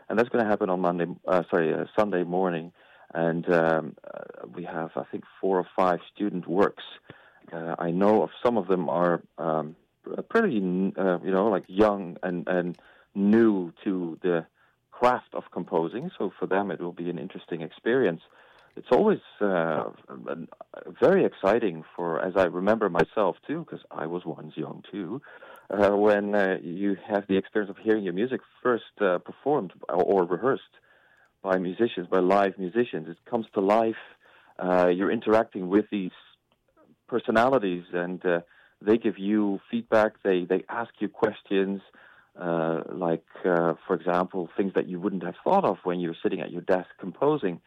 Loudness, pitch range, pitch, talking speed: -26 LUFS, 85-100 Hz, 90 Hz, 170 wpm